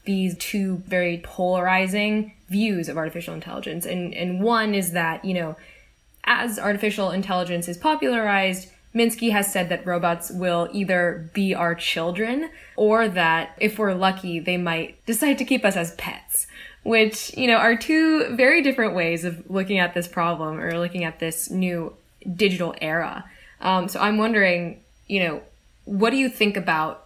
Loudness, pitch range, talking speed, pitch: -22 LUFS, 175-215 Hz, 165 wpm, 185 Hz